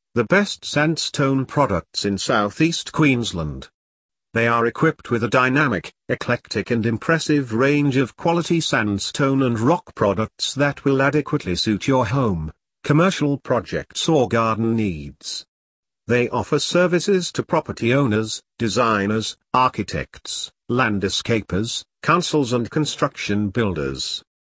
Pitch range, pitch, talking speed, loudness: 110-145 Hz, 125 Hz, 115 wpm, -20 LUFS